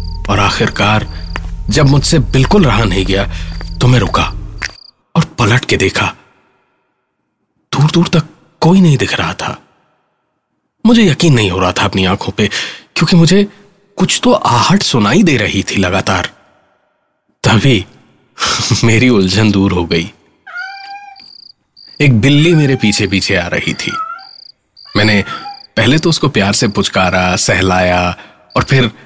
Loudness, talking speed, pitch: -11 LUFS, 135 wpm, 120 Hz